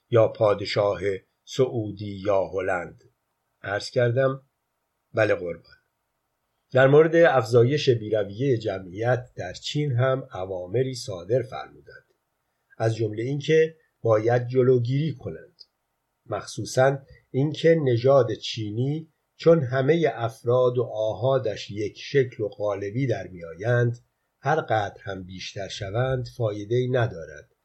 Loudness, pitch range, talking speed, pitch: -24 LUFS, 115-135 Hz, 105 wpm, 125 Hz